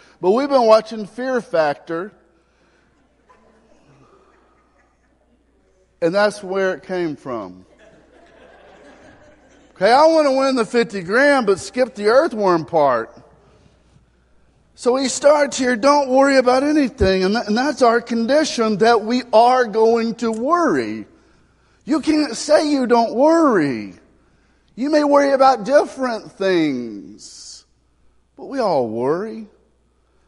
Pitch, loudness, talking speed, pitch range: 230 Hz, -17 LUFS, 115 wpm, 180-270 Hz